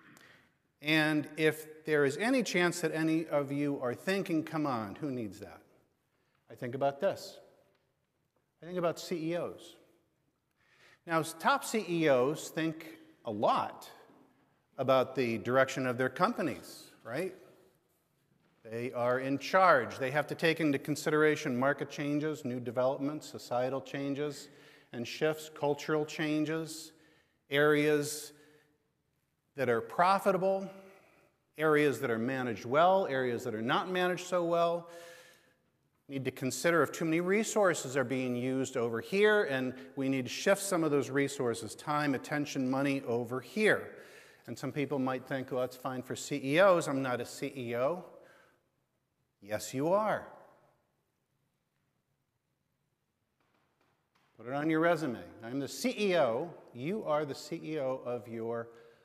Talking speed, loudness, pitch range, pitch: 135 wpm, -32 LUFS, 130-165 Hz, 150 Hz